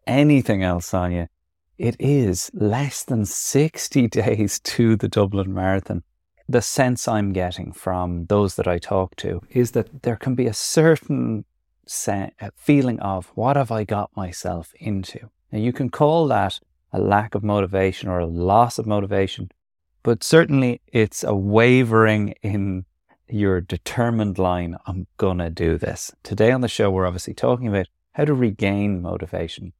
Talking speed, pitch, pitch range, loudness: 155 wpm, 105 Hz, 90-120 Hz, -21 LUFS